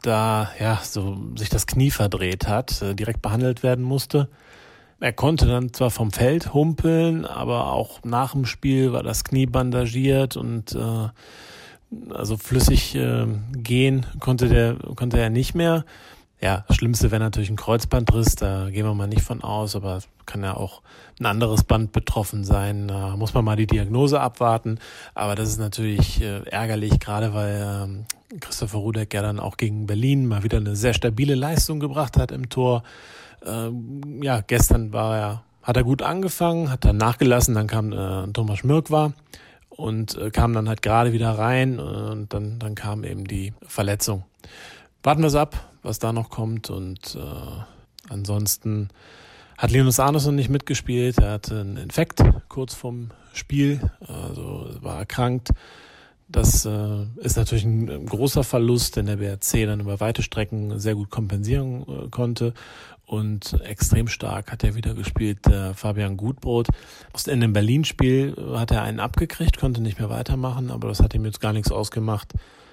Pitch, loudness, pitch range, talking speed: 115 Hz, -23 LUFS, 105-125 Hz, 165 wpm